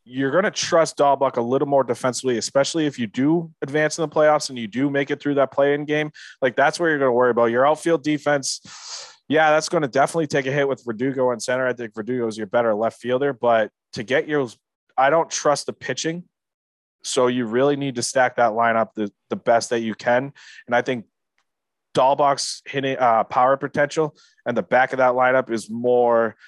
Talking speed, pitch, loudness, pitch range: 220 wpm, 135 Hz, -21 LUFS, 120-150 Hz